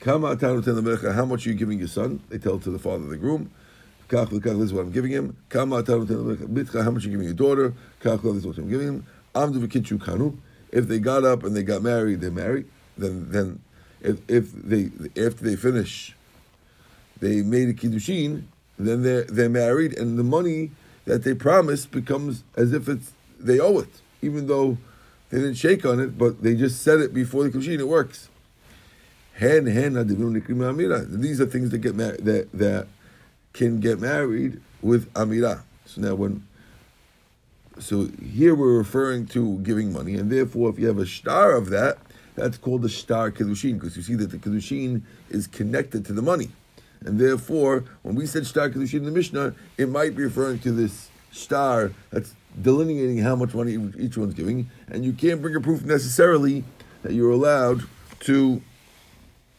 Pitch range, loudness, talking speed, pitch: 110-135 Hz, -23 LUFS, 175 wpm, 120 Hz